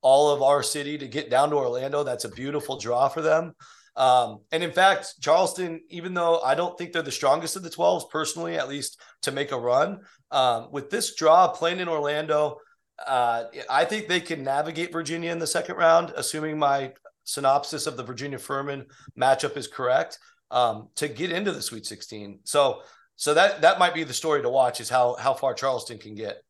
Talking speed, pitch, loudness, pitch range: 205 wpm, 150 Hz, -24 LUFS, 135-170 Hz